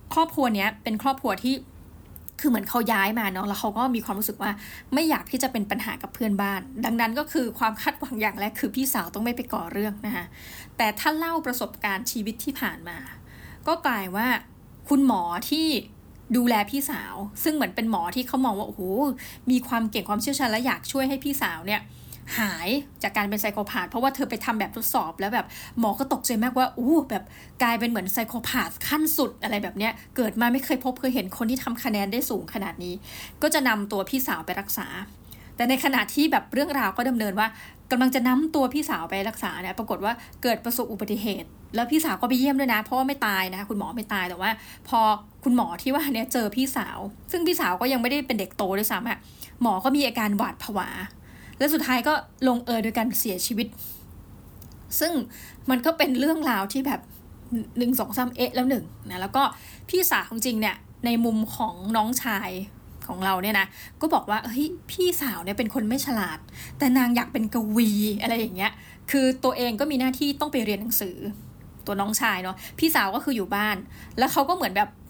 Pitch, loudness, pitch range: 240 Hz, -25 LUFS, 215-270 Hz